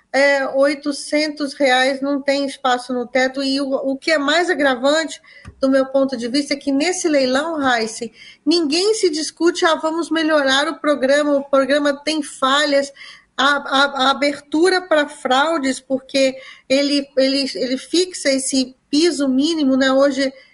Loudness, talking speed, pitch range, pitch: -17 LUFS, 155 wpm, 270-300 Hz, 280 Hz